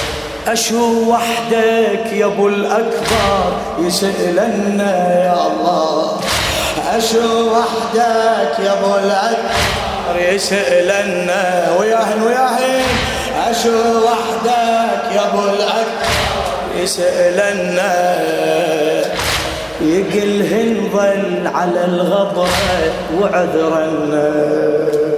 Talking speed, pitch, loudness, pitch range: 65 wpm, 205 Hz, -15 LUFS, 180-230 Hz